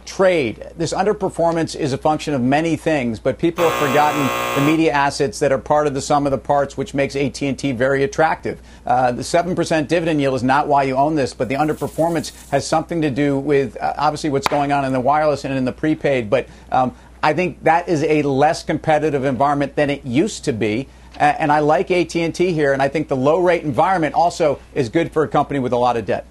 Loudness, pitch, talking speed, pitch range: -18 LUFS, 145 Hz, 230 wpm, 140-160 Hz